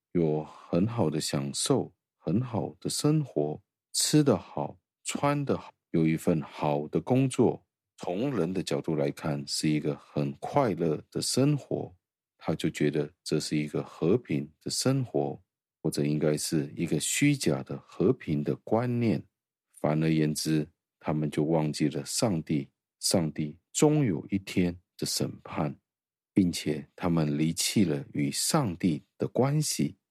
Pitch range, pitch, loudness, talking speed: 75-110 Hz, 80 Hz, -29 LUFS, 205 characters per minute